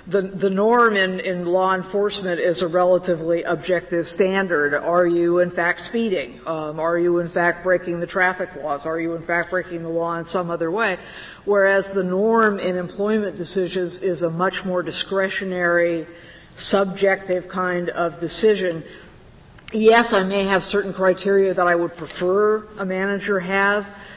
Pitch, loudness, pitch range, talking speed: 180 Hz, -20 LUFS, 170-195 Hz, 160 wpm